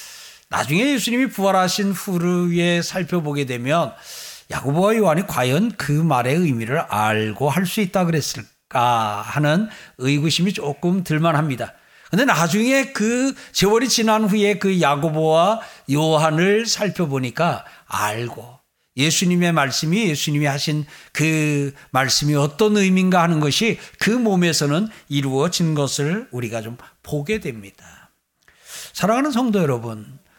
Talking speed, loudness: 280 characters per minute, -19 LUFS